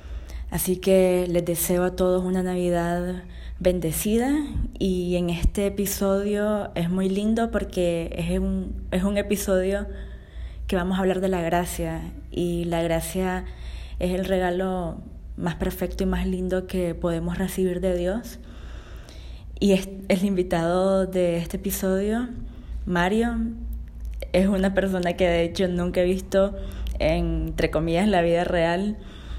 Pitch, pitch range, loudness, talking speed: 185 Hz, 175-195 Hz, -24 LUFS, 140 wpm